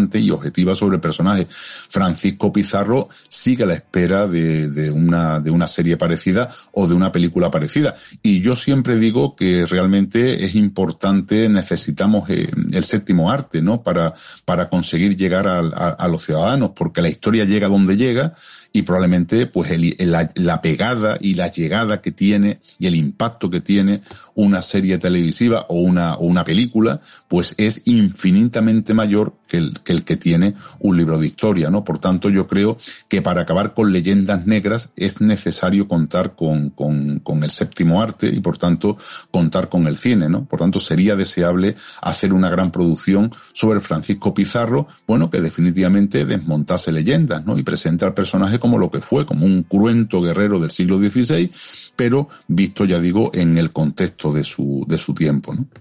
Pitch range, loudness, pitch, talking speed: 85-110 Hz, -17 LUFS, 95 Hz, 175 wpm